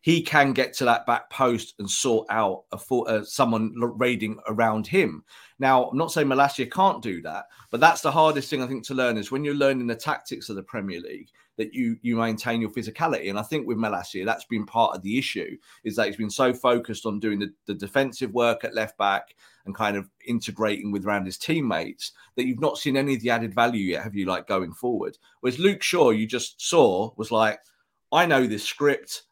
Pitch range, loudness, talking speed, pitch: 110-135 Hz, -24 LUFS, 225 wpm, 120 Hz